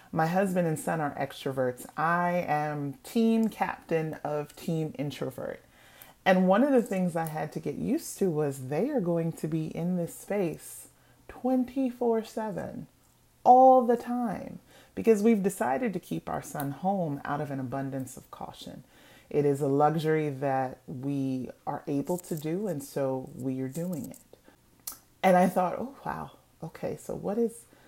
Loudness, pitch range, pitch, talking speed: -29 LUFS, 145-220 Hz, 165 Hz, 165 wpm